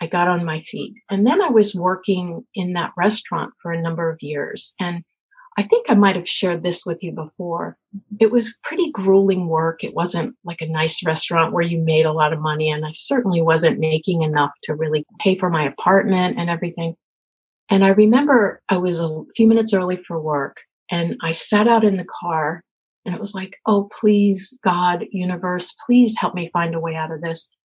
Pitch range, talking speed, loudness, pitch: 165-205 Hz, 210 wpm, -19 LUFS, 180 Hz